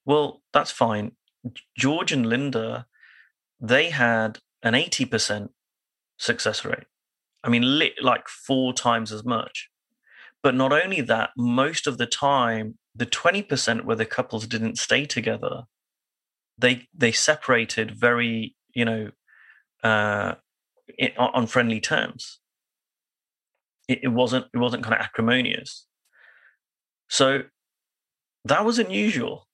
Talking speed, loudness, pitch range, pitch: 115 wpm, -23 LUFS, 115-135 Hz, 120 Hz